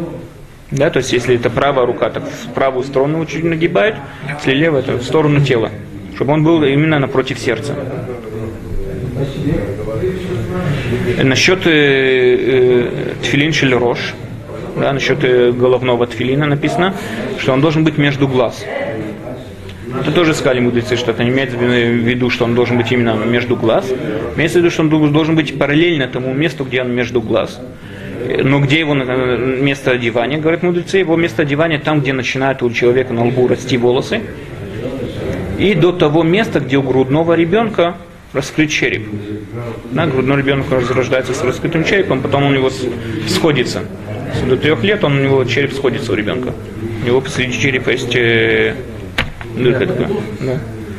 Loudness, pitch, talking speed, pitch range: -15 LUFS, 130 Hz, 145 wpm, 120-150 Hz